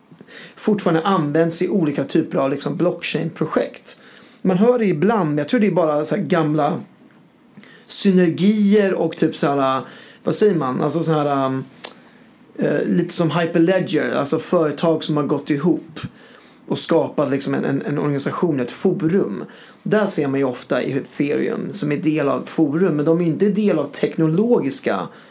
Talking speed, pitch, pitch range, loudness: 160 wpm, 165 Hz, 150-205 Hz, -19 LUFS